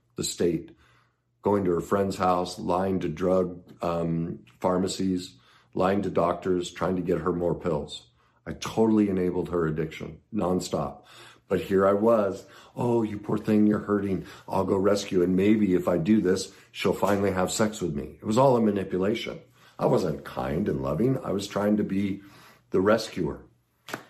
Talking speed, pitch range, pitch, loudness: 170 wpm, 90-105 Hz, 95 Hz, -26 LUFS